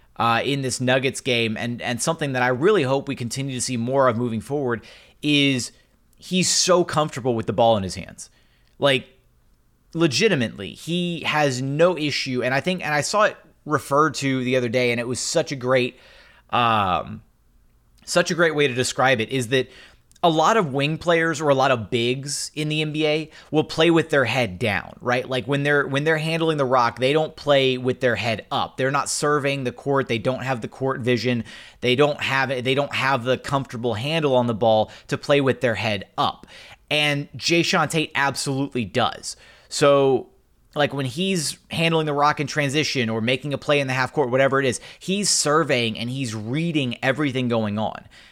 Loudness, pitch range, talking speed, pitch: -21 LUFS, 125-150 Hz, 200 wpm, 135 Hz